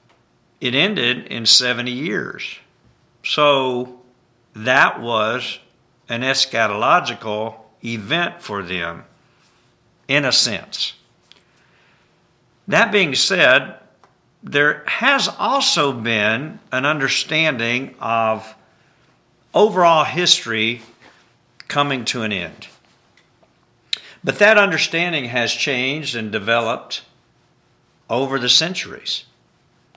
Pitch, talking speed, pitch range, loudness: 125 Hz, 85 wpm, 115-150 Hz, -17 LUFS